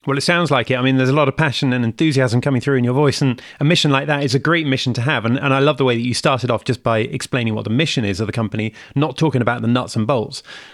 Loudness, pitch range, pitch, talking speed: -17 LUFS, 120-145 Hz, 130 Hz, 320 wpm